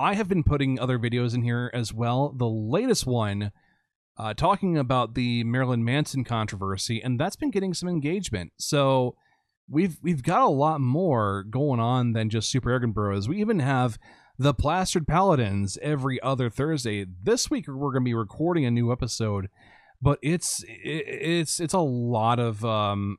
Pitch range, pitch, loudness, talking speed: 115-155 Hz, 130 Hz, -26 LUFS, 175 wpm